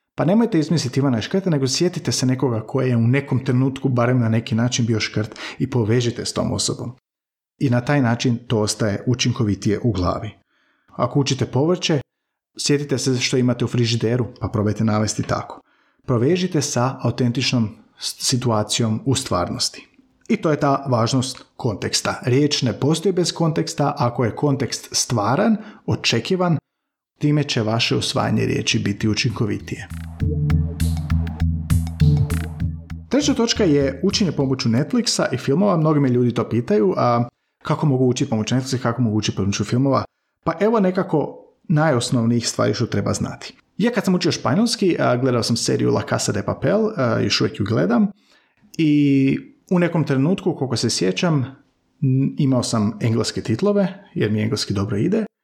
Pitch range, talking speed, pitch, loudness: 115-150 Hz, 155 wpm, 125 Hz, -20 LUFS